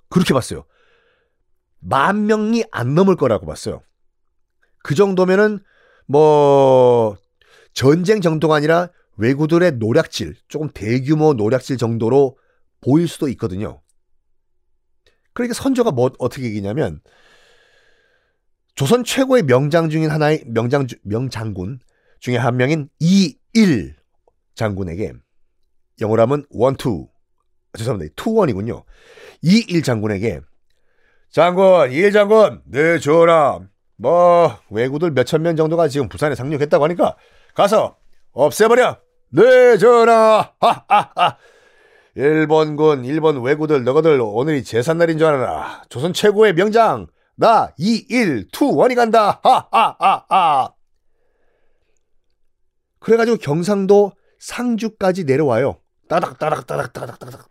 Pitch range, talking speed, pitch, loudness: 125-210 Hz, 255 characters per minute, 155 Hz, -16 LUFS